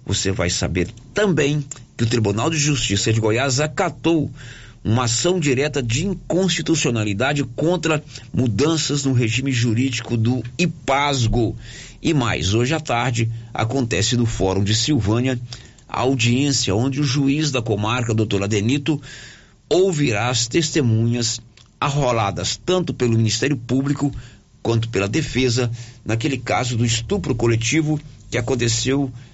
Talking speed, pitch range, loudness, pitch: 125 wpm, 115-145 Hz, -20 LUFS, 125 Hz